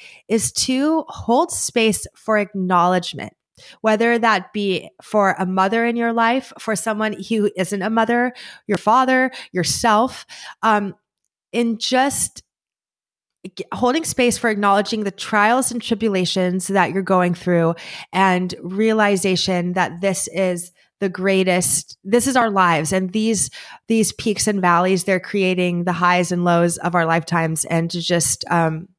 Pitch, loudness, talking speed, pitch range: 195 Hz, -19 LUFS, 145 wpm, 180-225 Hz